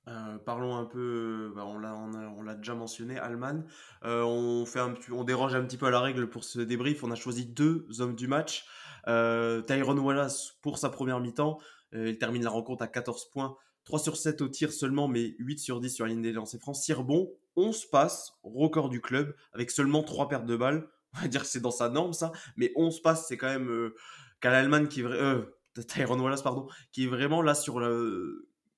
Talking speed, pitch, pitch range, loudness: 220 wpm, 130 Hz, 120-145 Hz, -31 LUFS